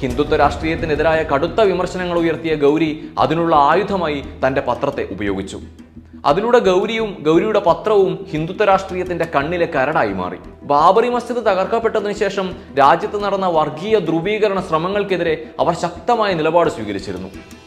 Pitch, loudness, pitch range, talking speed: 170 Hz, -17 LUFS, 145-195 Hz, 110 wpm